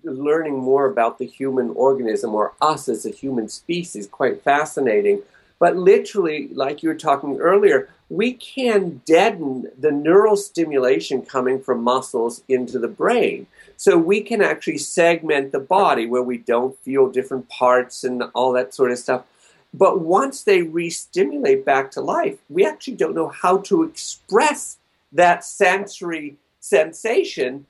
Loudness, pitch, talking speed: -19 LUFS, 165 Hz, 155 wpm